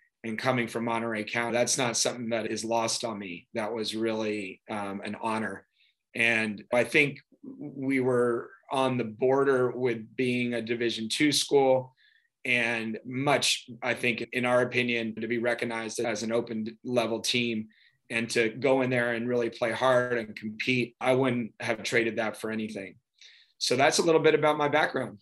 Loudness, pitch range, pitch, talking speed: -27 LUFS, 115-130 Hz, 120 Hz, 175 wpm